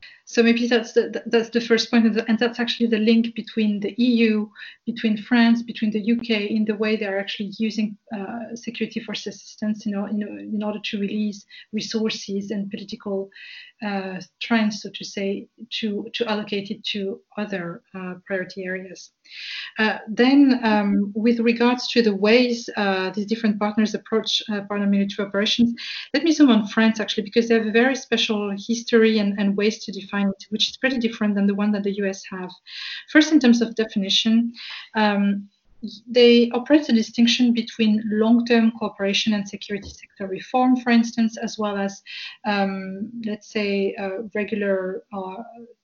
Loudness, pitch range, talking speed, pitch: -22 LUFS, 205-230 Hz, 175 wpm, 215 Hz